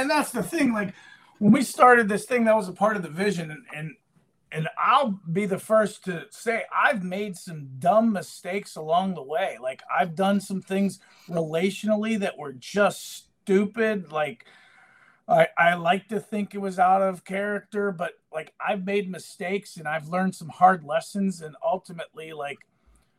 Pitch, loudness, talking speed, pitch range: 195 Hz, -25 LUFS, 180 wpm, 170-210 Hz